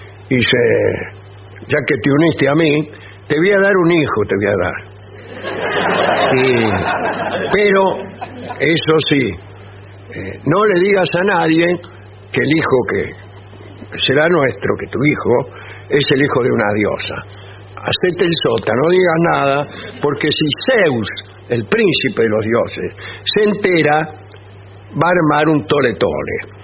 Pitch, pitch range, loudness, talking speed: 130 Hz, 100-160 Hz, -15 LUFS, 145 wpm